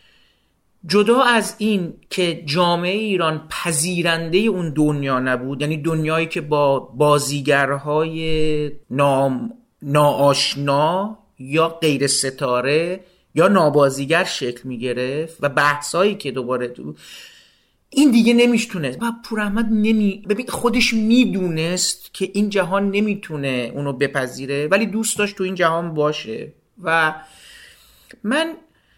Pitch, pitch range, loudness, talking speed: 165 Hz, 145-200 Hz, -19 LUFS, 110 wpm